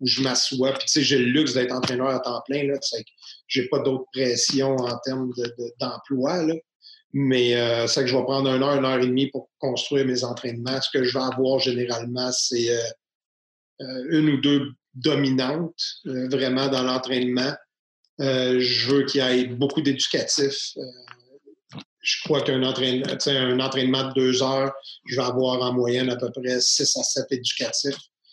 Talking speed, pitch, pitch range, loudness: 195 wpm, 130 Hz, 125-135 Hz, -23 LUFS